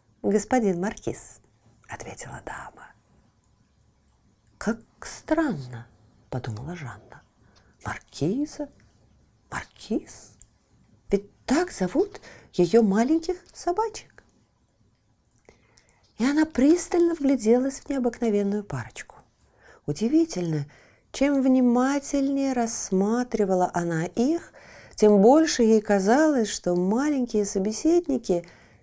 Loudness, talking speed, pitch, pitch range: -24 LUFS, 75 wpm, 230 Hz, 180-280 Hz